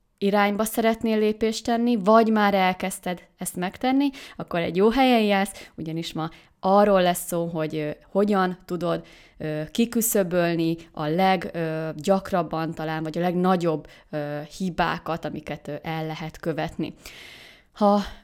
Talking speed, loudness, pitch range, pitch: 115 wpm, -24 LUFS, 160-205 Hz, 180 Hz